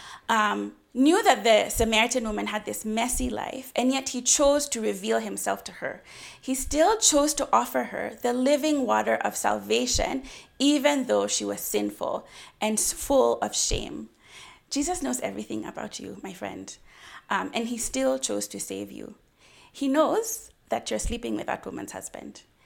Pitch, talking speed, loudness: 245 Hz, 165 wpm, -25 LUFS